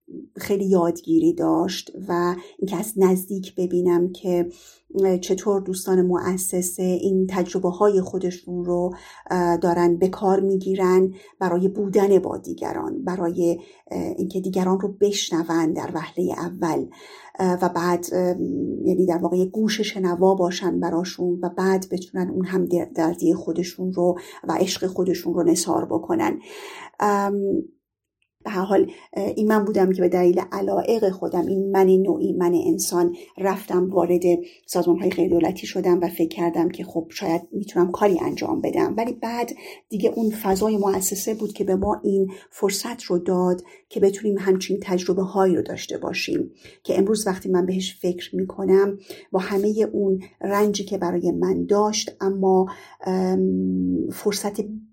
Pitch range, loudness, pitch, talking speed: 175-200 Hz, -22 LUFS, 185 Hz, 140 wpm